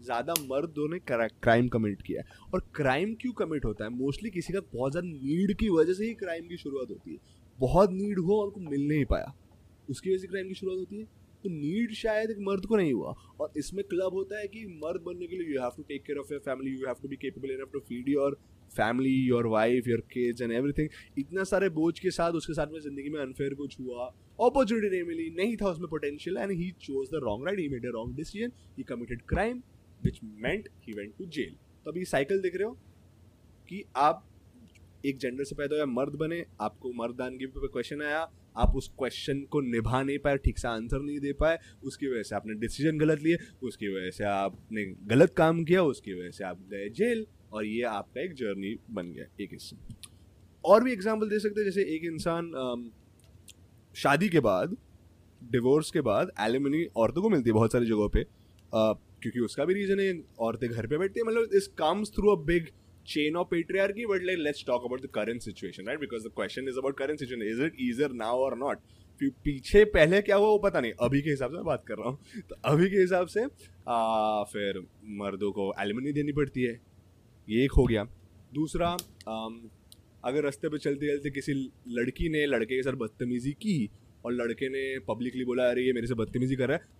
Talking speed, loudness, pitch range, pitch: 215 wpm, -30 LUFS, 115-175 Hz, 140 Hz